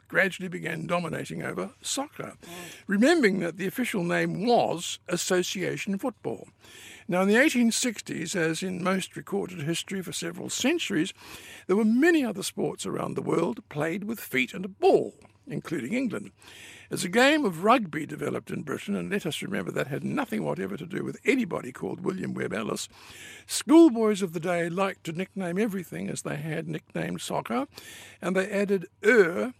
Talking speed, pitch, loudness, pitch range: 165 wpm, 190 Hz, -27 LUFS, 175-230 Hz